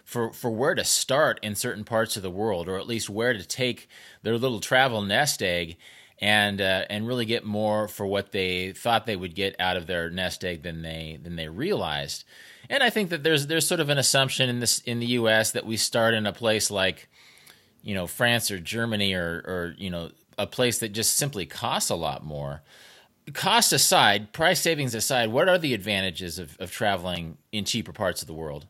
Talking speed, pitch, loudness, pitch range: 215 wpm, 105 Hz, -25 LUFS, 90-120 Hz